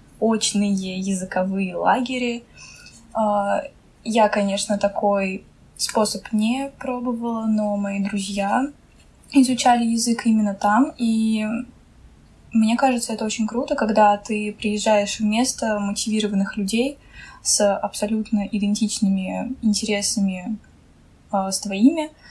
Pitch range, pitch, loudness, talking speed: 205-235 Hz, 215 Hz, -21 LUFS, 95 wpm